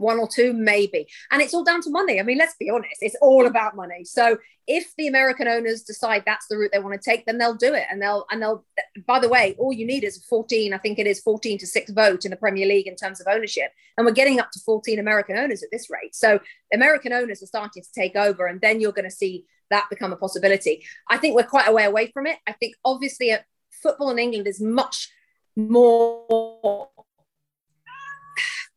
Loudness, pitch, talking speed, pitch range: -21 LUFS, 225 Hz, 230 wpm, 205-260 Hz